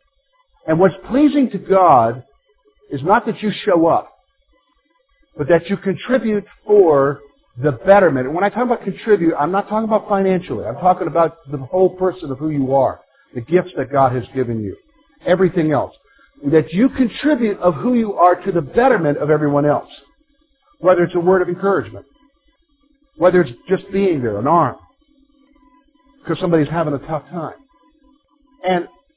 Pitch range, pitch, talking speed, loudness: 160-260 Hz, 190 Hz, 165 wpm, -17 LUFS